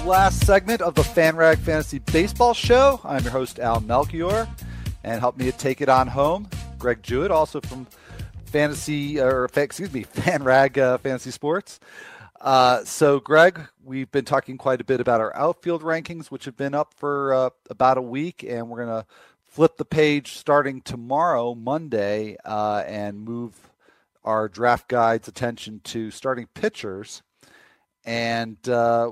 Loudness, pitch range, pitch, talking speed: -22 LUFS, 115-150 Hz, 130 Hz, 160 wpm